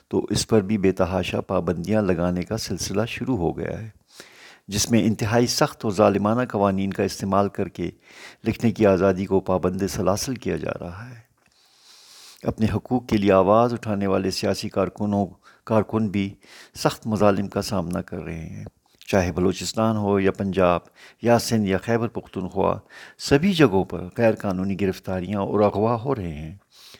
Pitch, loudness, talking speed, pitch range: 100 Hz, -23 LUFS, 165 wpm, 95-110 Hz